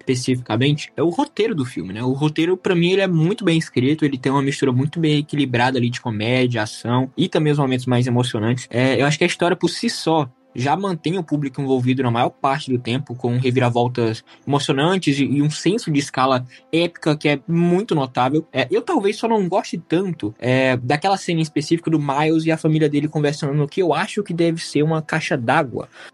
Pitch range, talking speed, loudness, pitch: 130-165 Hz, 220 wpm, -19 LUFS, 145 Hz